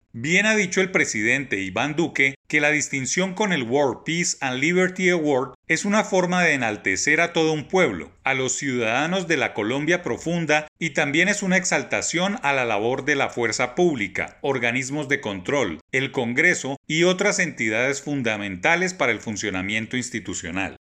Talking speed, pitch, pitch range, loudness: 165 wpm, 145 Hz, 120-175 Hz, -22 LUFS